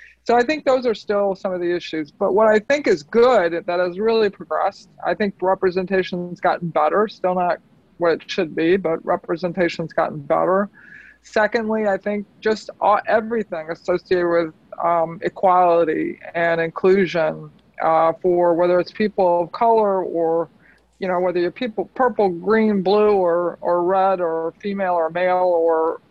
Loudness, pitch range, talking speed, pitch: -20 LUFS, 170-210 Hz, 165 wpm, 185 Hz